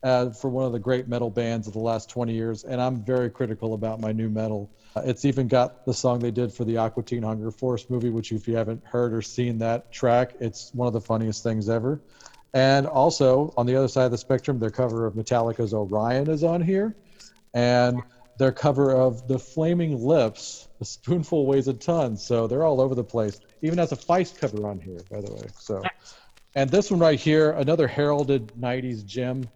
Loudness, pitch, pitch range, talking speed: -24 LUFS, 125 Hz, 115-135 Hz, 215 wpm